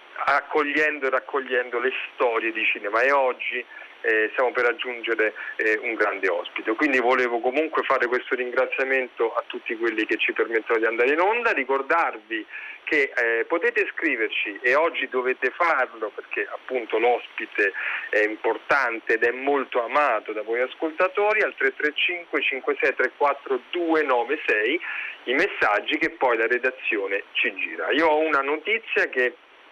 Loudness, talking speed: -23 LUFS, 145 wpm